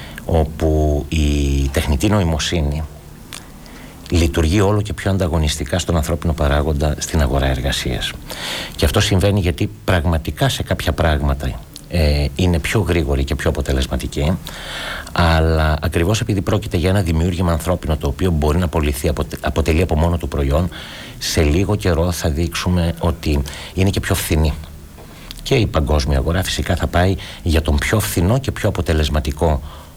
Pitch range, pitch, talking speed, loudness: 75-90 Hz, 85 Hz, 145 wpm, -18 LUFS